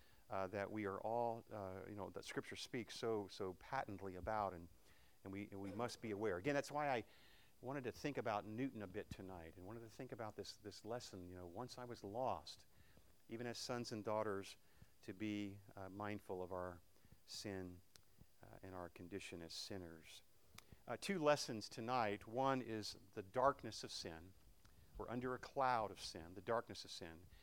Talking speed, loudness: 190 wpm, -47 LUFS